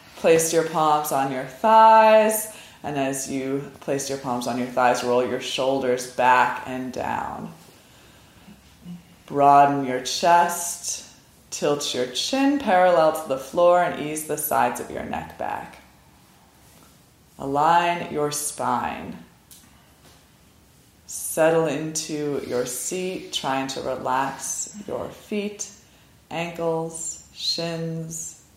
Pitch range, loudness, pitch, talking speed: 130-170 Hz, -22 LUFS, 150 Hz, 110 wpm